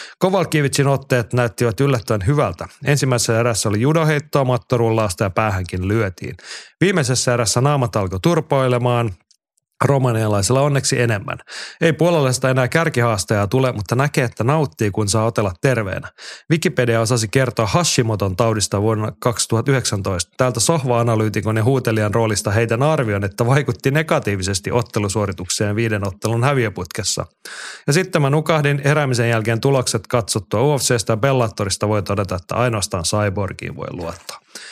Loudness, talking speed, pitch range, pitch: -18 LUFS, 125 wpm, 110-140 Hz, 120 Hz